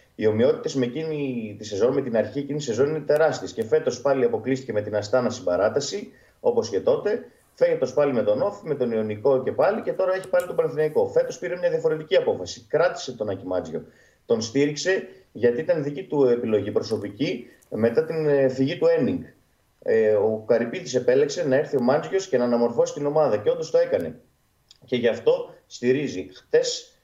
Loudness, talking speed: -23 LUFS, 185 wpm